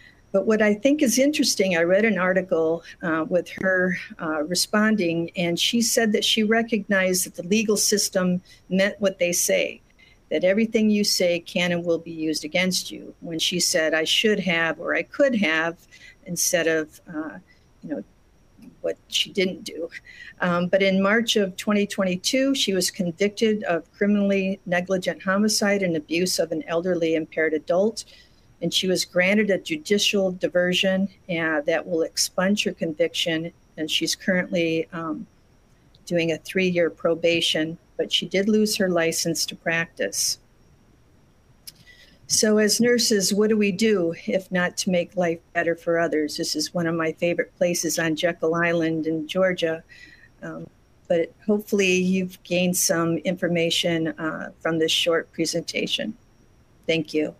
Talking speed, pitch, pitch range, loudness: 155 wpm, 180 Hz, 165-200 Hz, -22 LUFS